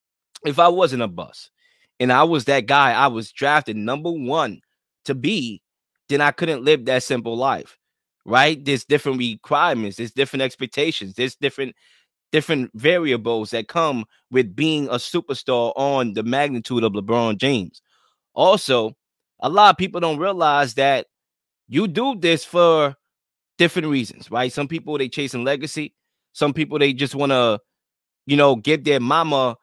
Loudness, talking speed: -20 LUFS, 160 wpm